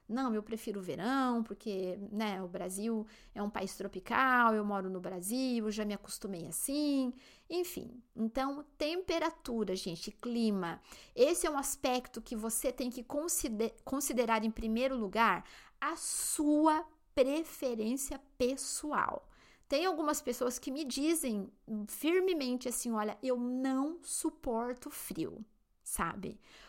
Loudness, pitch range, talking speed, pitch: -35 LUFS, 215-285 Hz, 130 wpm, 250 Hz